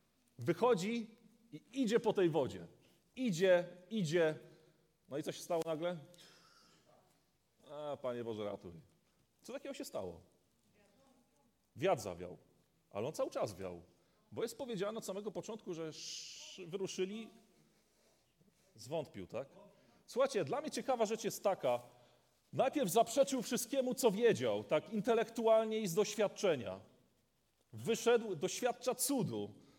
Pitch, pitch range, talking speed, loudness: 185 Hz, 150-225 Hz, 120 wpm, -37 LUFS